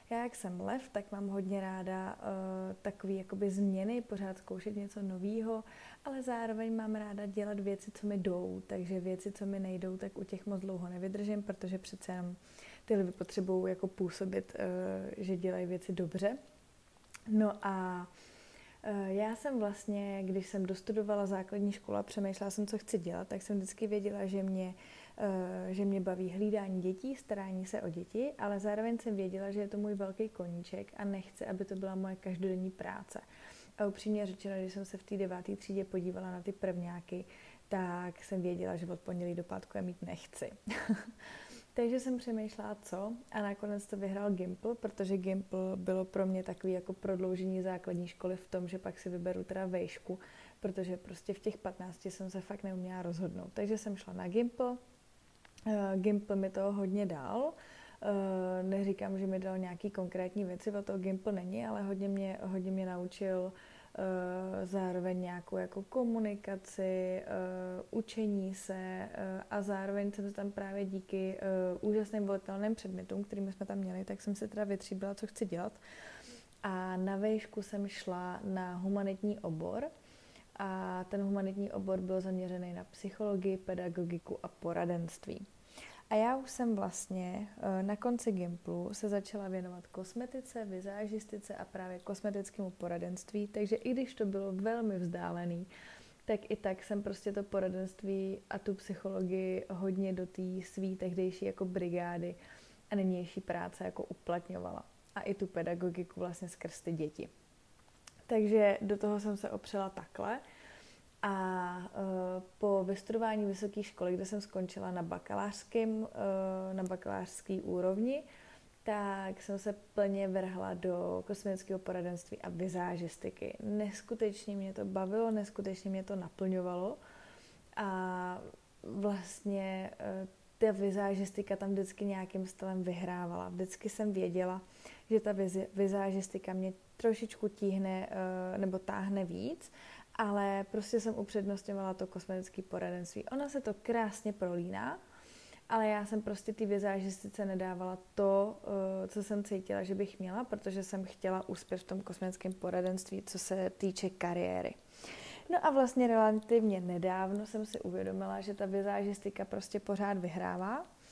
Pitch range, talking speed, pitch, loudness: 185-205 Hz, 150 wpm, 195 Hz, -38 LUFS